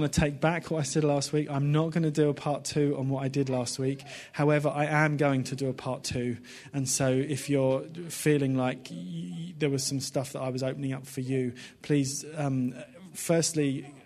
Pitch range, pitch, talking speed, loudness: 130-150 Hz, 140 Hz, 220 wpm, -29 LUFS